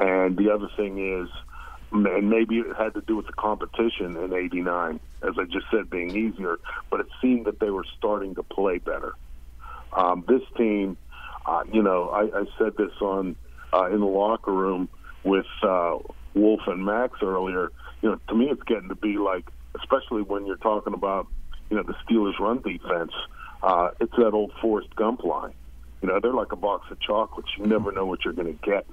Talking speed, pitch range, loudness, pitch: 200 wpm, 90-105 Hz, -26 LUFS, 100 Hz